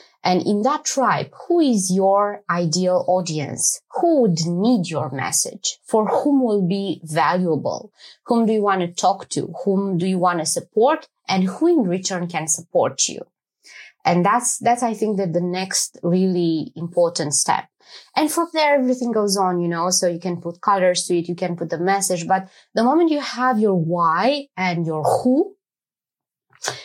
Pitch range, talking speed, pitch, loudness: 175-240 Hz, 180 wpm, 185 Hz, -20 LUFS